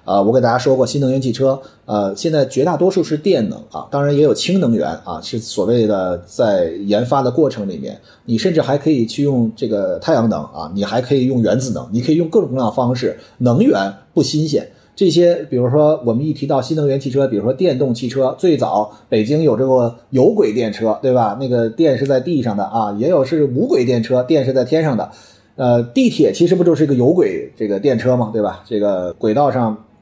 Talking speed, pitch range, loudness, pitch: 325 characters per minute, 115-155 Hz, -16 LUFS, 130 Hz